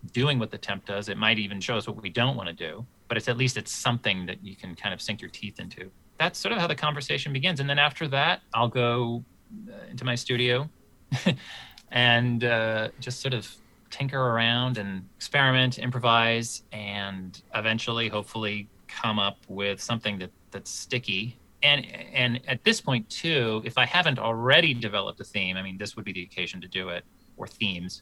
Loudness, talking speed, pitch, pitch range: -26 LUFS, 195 wpm, 115 Hz, 105-130 Hz